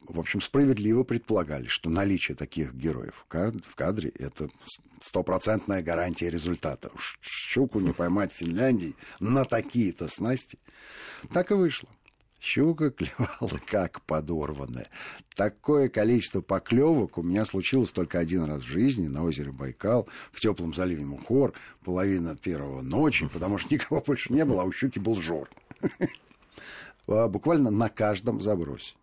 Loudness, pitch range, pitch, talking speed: -28 LUFS, 85-115 Hz, 95 Hz, 135 wpm